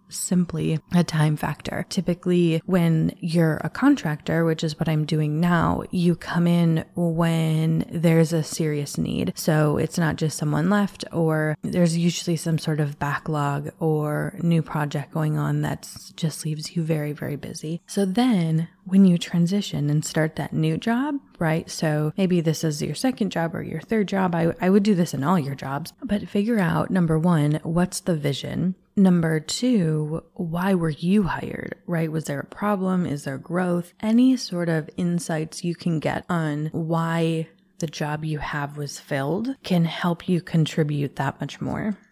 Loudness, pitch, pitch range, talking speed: -23 LUFS, 165 Hz, 155-180 Hz, 175 wpm